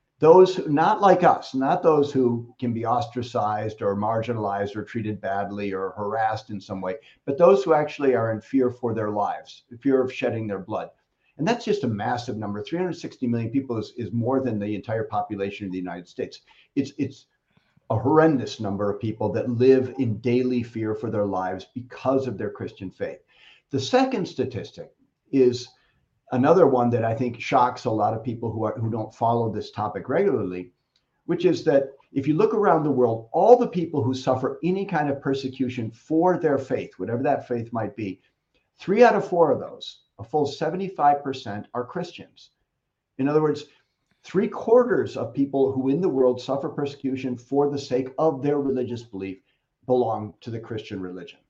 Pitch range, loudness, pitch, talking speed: 110-140 Hz, -24 LUFS, 125 Hz, 185 wpm